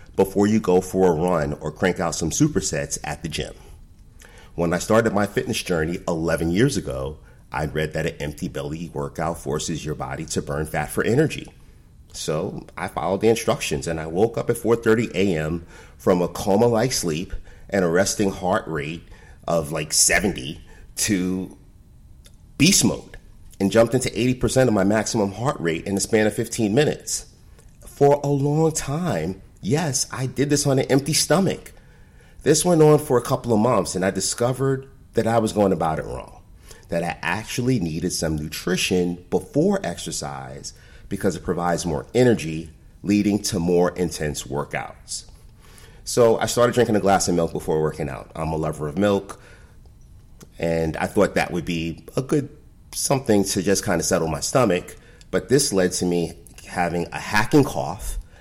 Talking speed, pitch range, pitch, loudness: 175 wpm, 85-115 Hz, 95 Hz, -22 LUFS